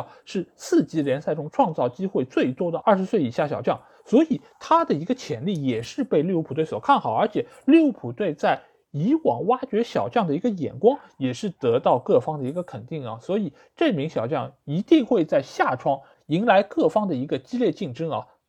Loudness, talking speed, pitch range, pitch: -23 LUFS, 300 characters per minute, 155-260 Hz, 205 Hz